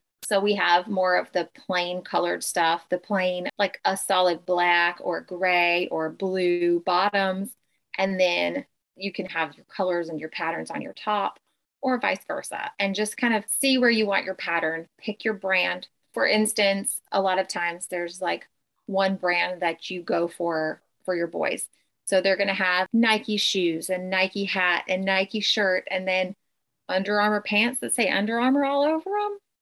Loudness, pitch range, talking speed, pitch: -24 LUFS, 175-205 Hz, 185 wpm, 190 Hz